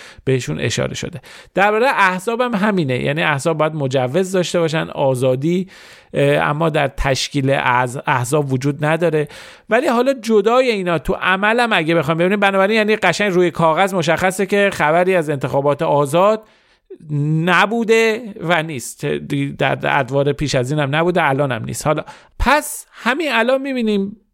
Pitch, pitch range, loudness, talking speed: 165 Hz, 145-200 Hz, -17 LUFS, 145 wpm